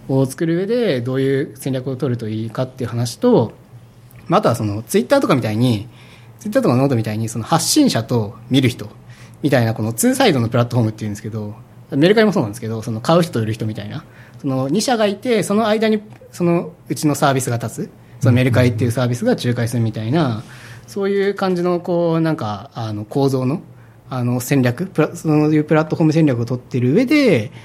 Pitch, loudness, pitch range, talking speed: 130 Hz, -18 LUFS, 120-165 Hz, 450 characters per minute